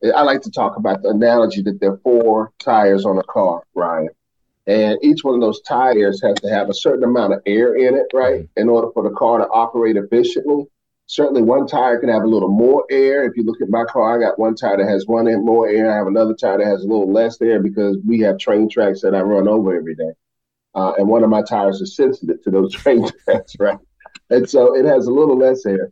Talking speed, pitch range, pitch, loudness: 250 wpm, 105-120 Hz, 115 Hz, -16 LUFS